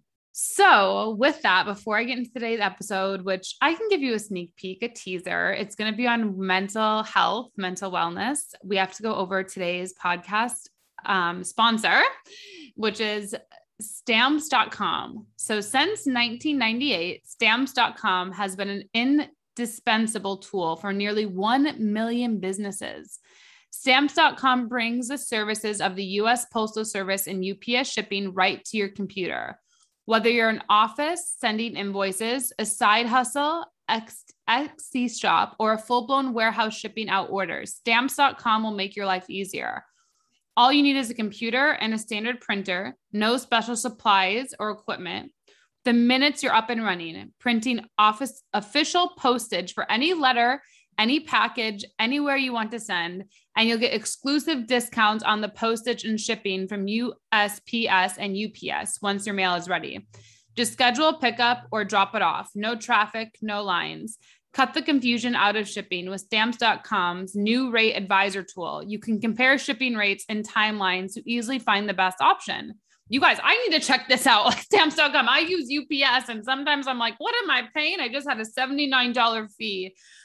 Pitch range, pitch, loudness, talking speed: 200-255 Hz, 225 Hz, -24 LUFS, 160 wpm